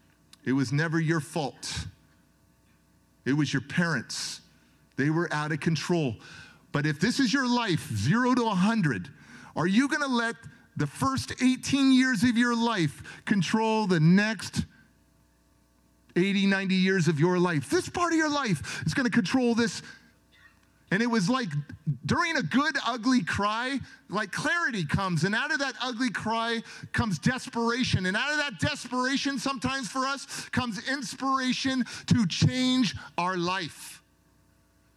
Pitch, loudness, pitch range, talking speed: 210 Hz, -27 LUFS, 155-255 Hz, 150 wpm